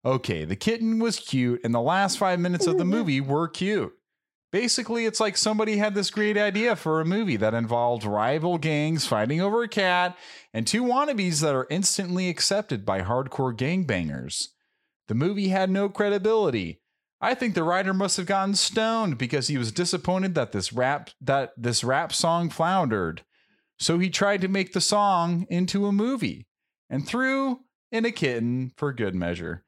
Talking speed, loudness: 175 wpm, -25 LUFS